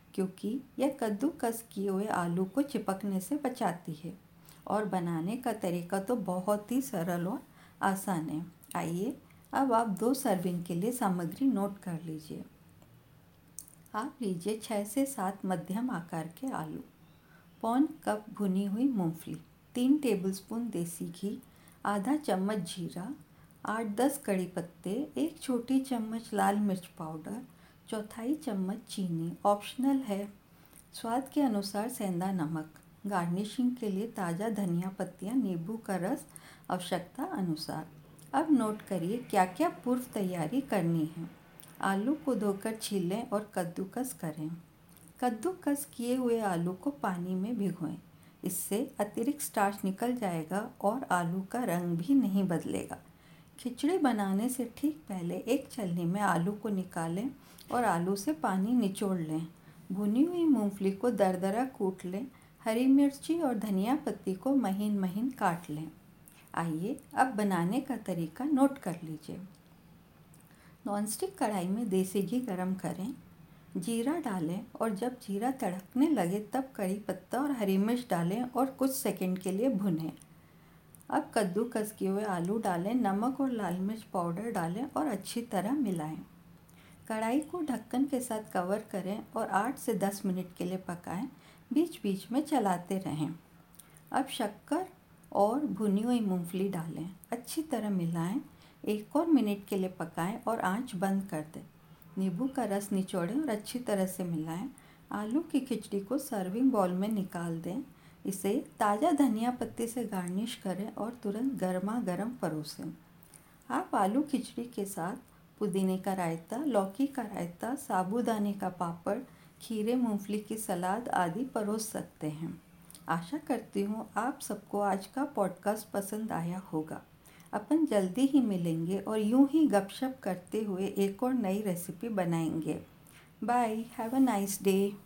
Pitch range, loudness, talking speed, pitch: 185-245 Hz, -33 LUFS, 145 wpm, 205 Hz